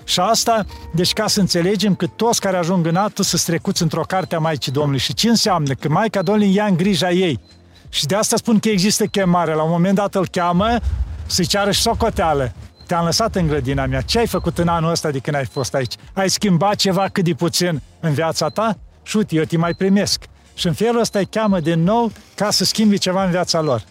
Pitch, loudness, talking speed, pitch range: 180 Hz, -18 LUFS, 230 wpm, 160-205 Hz